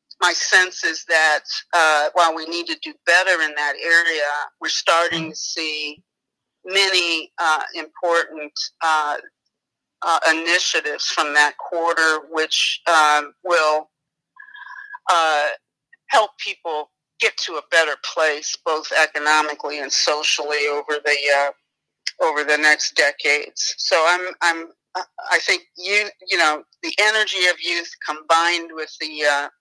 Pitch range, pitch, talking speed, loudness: 150-180 Hz, 160 Hz, 130 wpm, -19 LUFS